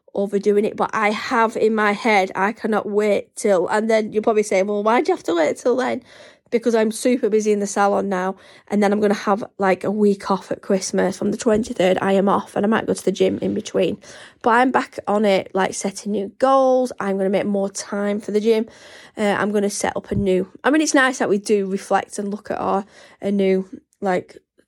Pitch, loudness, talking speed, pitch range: 205 Hz, -20 LUFS, 250 wpm, 195-225 Hz